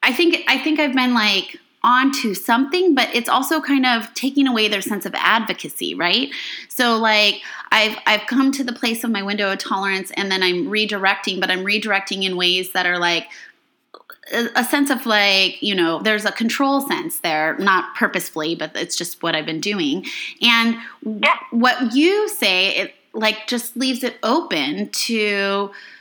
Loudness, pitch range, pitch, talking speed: -18 LUFS, 195-270 Hz, 230 Hz, 180 wpm